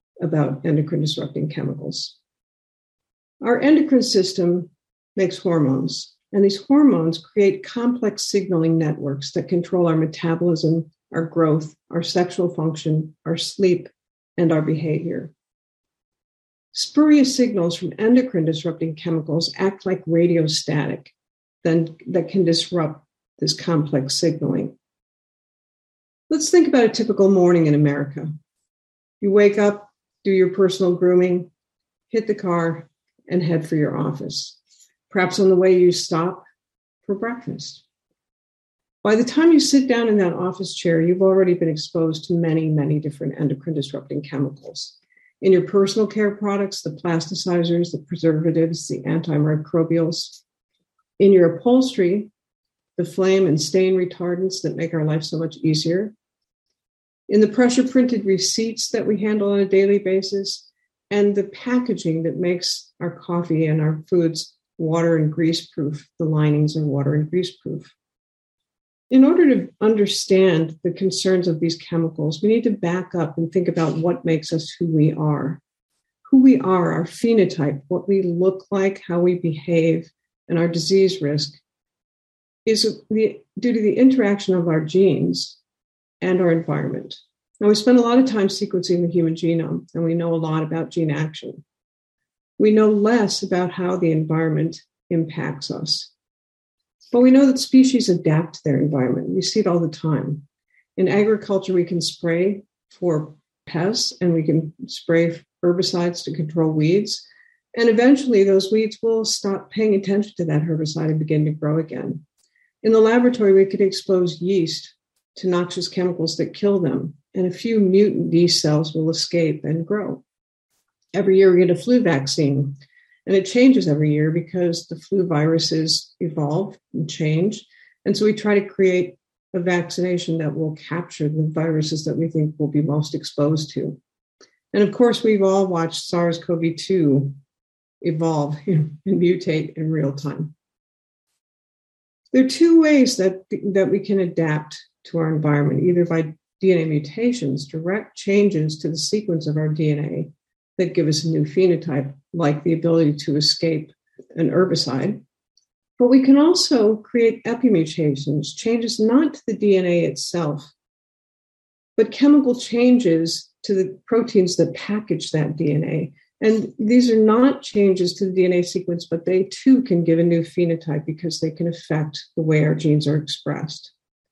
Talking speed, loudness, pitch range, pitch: 155 wpm, -19 LUFS, 155-200 Hz, 175 Hz